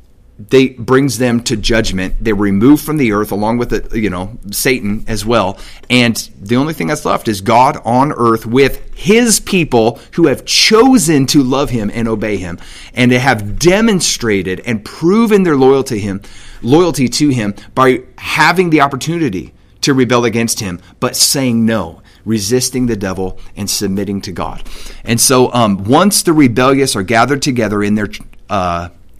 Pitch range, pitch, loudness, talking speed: 105-135 Hz, 115 Hz, -12 LUFS, 170 wpm